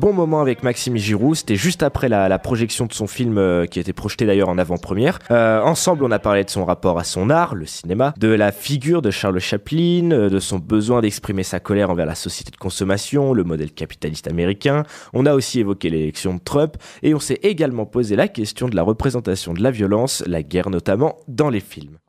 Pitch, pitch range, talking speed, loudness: 105 Hz, 95-130 Hz, 225 wpm, -19 LUFS